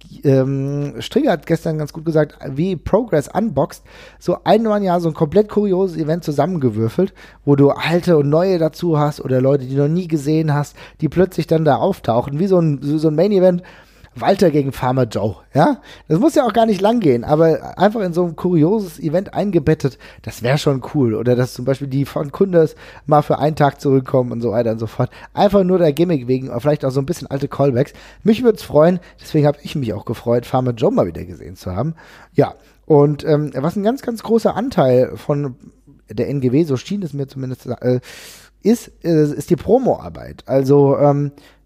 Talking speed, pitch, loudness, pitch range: 205 wpm, 150 Hz, -17 LUFS, 135-175 Hz